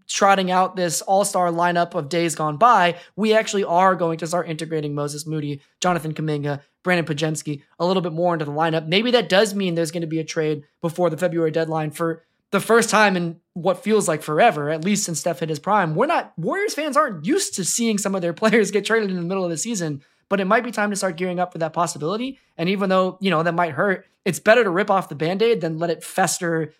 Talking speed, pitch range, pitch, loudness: 250 wpm, 165-200 Hz, 175 Hz, -21 LUFS